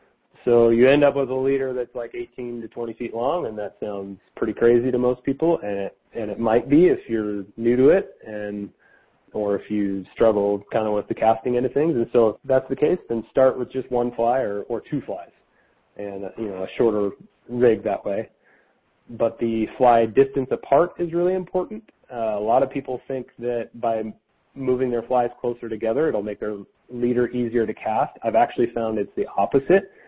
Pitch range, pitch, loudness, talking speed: 110-130 Hz, 120 Hz, -22 LUFS, 210 wpm